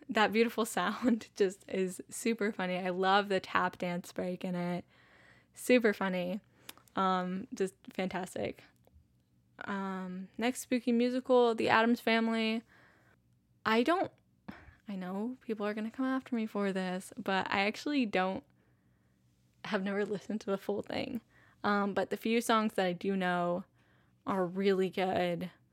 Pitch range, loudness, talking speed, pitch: 180-225 Hz, -33 LUFS, 145 wpm, 195 Hz